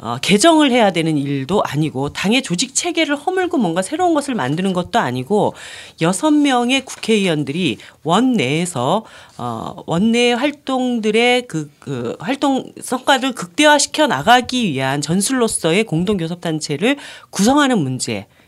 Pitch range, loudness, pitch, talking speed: 160-265 Hz, -17 LUFS, 225 Hz, 300 characters per minute